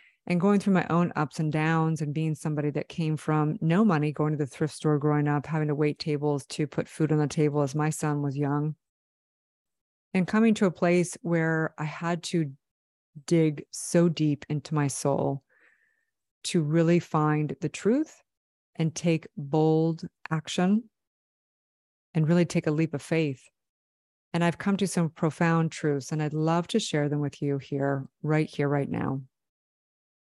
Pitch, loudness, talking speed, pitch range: 155 Hz, -27 LUFS, 175 wpm, 150-170 Hz